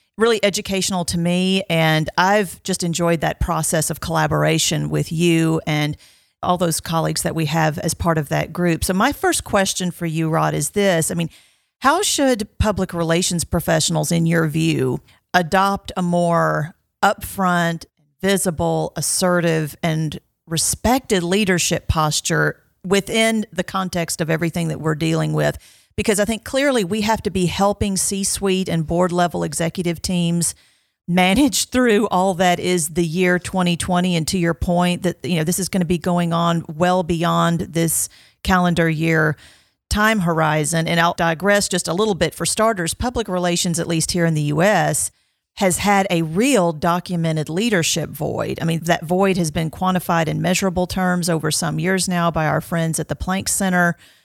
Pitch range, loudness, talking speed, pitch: 165-190 Hz, -19 LUFS, 170 wpm, 175 Hz